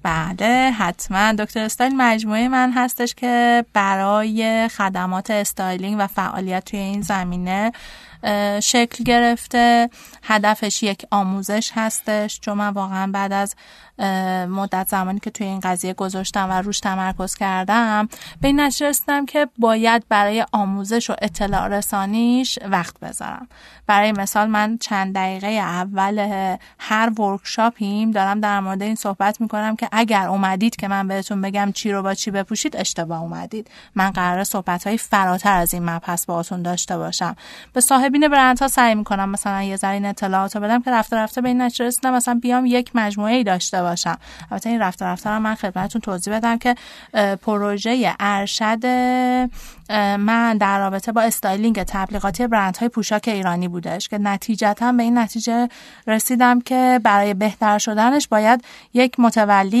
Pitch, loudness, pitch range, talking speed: 210 Hz, -19 LUFS, 195-235 Hz, 155 wpm